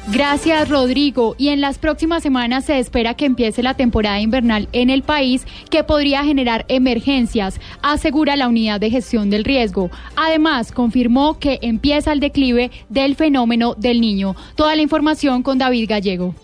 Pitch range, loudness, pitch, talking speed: 235-290 Hz, -16 LUFS, 260 Hz, 160 wpm